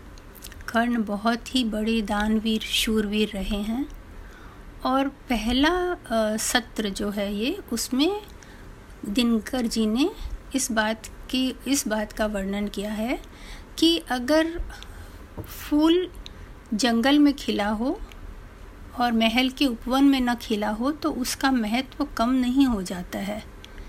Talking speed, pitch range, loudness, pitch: 125 wpm, 215-275 Hz, -24 LUFS, 240 Hz